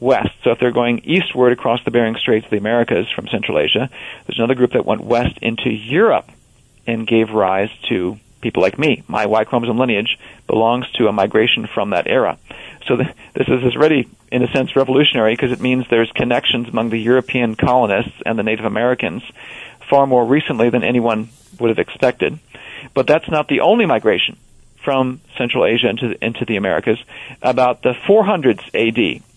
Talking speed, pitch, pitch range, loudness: 185 wpm, 120 Hz, 115-125 Hz, -16 LUFS